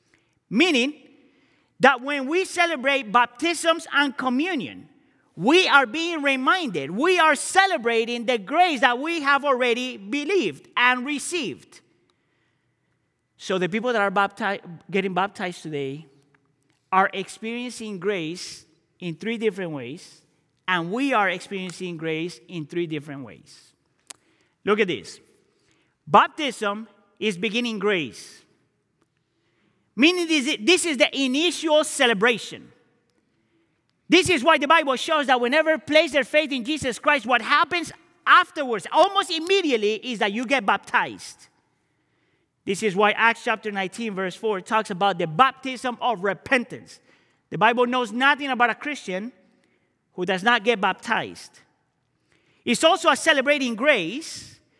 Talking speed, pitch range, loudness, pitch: 130 wpm, 200-295 Hz, -22 LUFS, 245 Hz